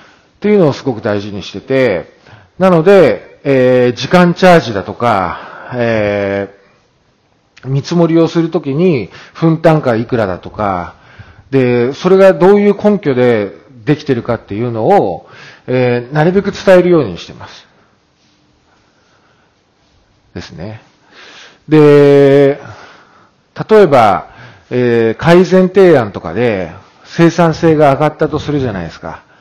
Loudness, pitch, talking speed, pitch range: -11 LUFS, 135 Hz, 250 characters per minute, 115-170 Hz